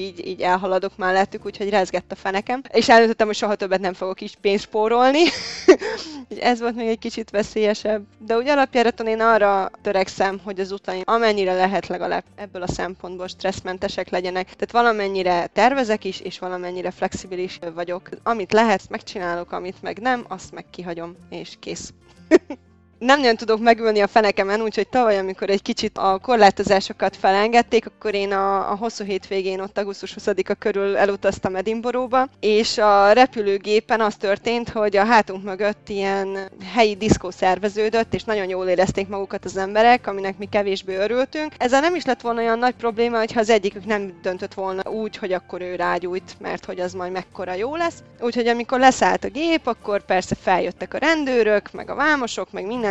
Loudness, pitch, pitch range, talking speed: -20 LUFS, 205 Hz, 190-230 Hz, 170 wpm